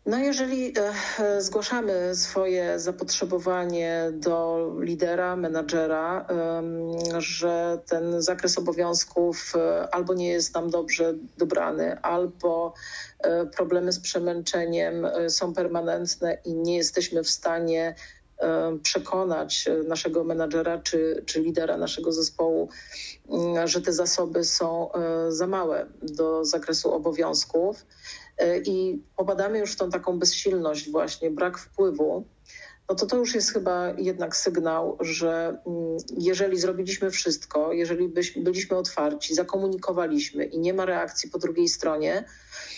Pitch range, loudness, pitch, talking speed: 165-185 Hz, -26 LUFS, 175 Hz, 110 wpm